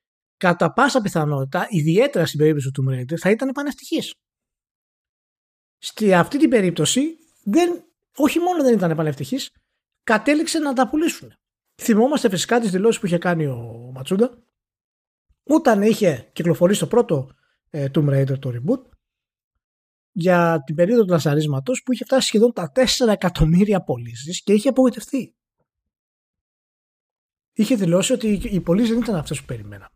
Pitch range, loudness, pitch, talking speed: 160-255 Hz, -19 LUFS, 200 Hz, 140 wpm